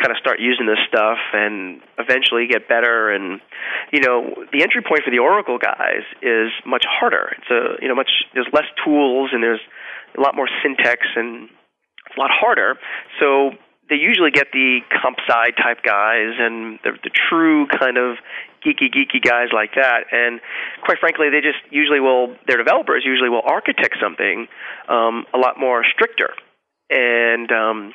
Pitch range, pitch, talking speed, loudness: 115-145 Hz, 125 Hz, 175 wpm, -16 LUFS